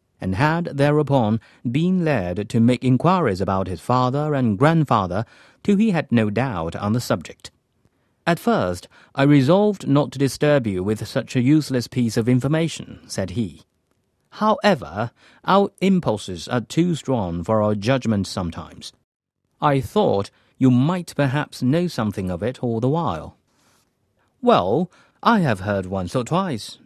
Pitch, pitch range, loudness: 125 Hz, 105-150 Hz, -21 LUFS